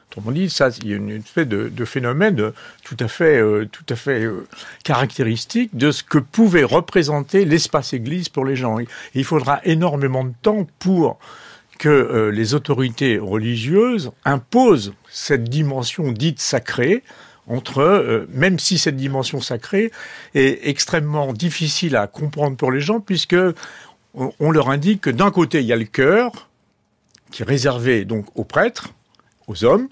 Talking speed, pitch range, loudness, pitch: 160 wpm, 125-175 Hz, -18 LUFS, 145 Hz